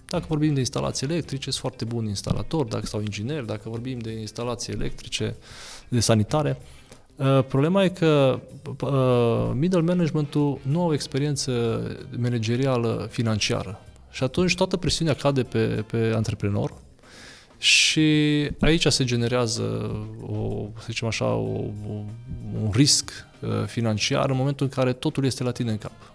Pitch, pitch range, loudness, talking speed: 125 Hz, 110-140 Hz, -24 LUFS, 135 wpm